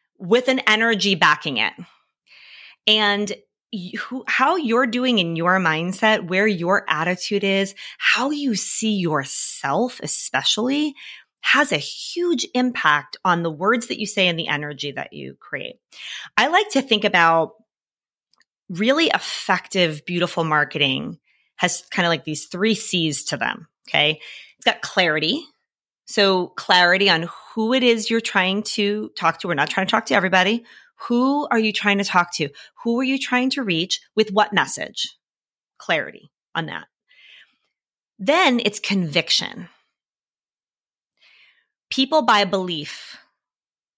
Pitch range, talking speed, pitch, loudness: 170-230 Hz, 140 wpm, 200 Hz, -19 LUFS